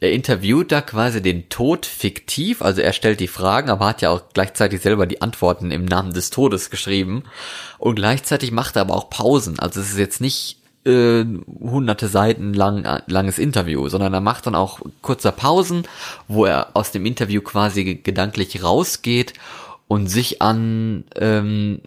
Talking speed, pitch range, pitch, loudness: 170 wpm, 95-115 Hz, 105 Hz, -19 LUFS